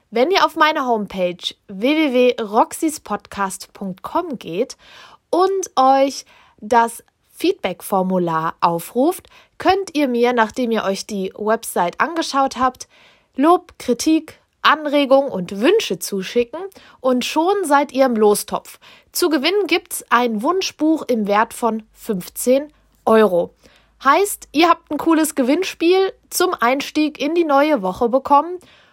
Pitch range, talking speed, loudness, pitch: 220-315 Hz, 120 wpm, -18 LUFS, 265 Hz